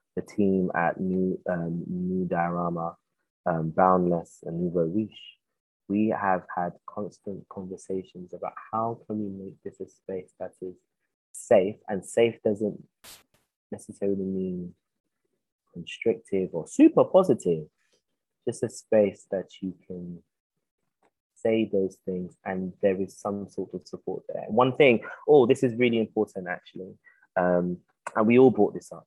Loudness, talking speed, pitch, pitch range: -26 LUFS, 140 wpm, 95 Hz, 90-110 Hz